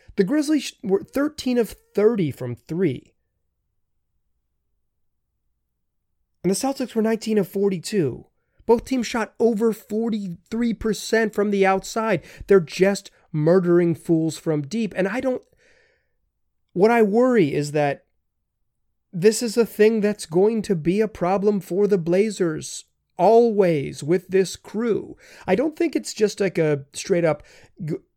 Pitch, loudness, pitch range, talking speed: 195 Hz, -22 LUFS, 160-225 Hz, 135 wpm